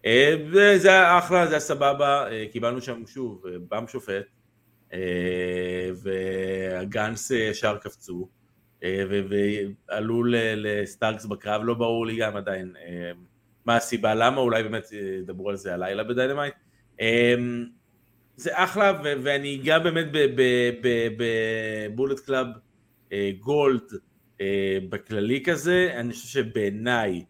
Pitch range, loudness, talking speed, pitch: 100-130 Hz, -24 LUFS, 105 wpm, 115 Hz